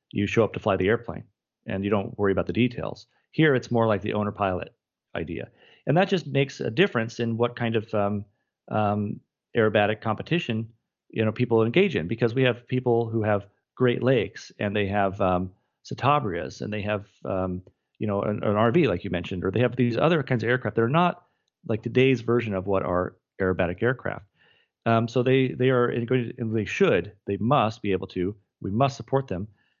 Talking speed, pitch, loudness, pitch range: 205 wpm, 110 Hz, -25 LUFS, 100-125 Hz